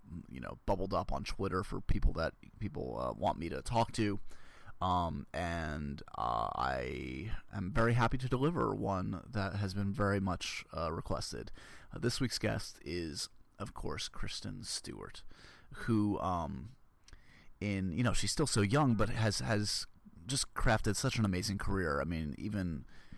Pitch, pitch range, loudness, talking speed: 100 Hz, 90-115 Hz, -36 LUFS, 165 wpm